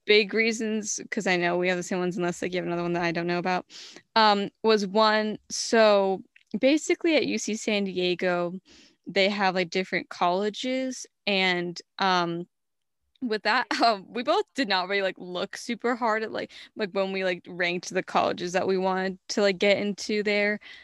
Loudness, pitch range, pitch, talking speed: -26 LUFS, 180-220 Hz, 200 Hz, 190 wpm